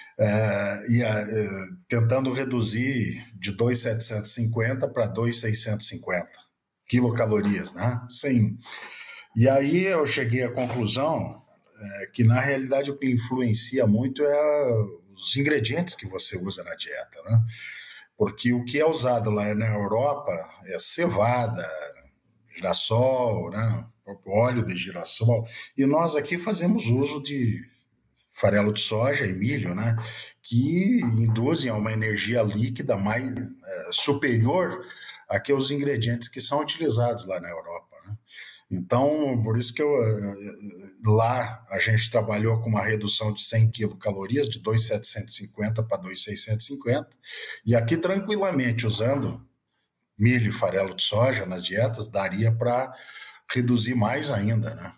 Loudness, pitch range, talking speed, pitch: -24 LUFS, 110-130 Hz, 130 wpm, 115 Hz